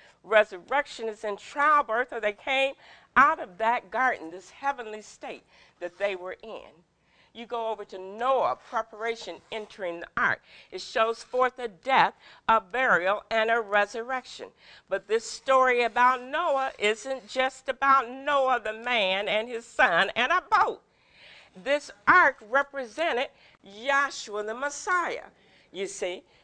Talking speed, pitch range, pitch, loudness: 140 wpm, 215-270 Hz, 235 Hz, -26 LUFS